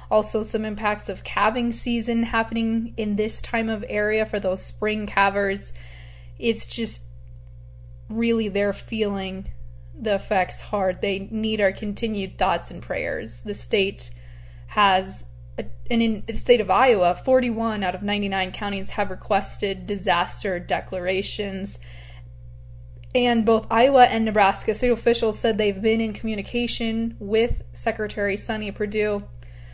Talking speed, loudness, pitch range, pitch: 135 wpm, -23 LUFS, 185-225 Hz, 205 Hz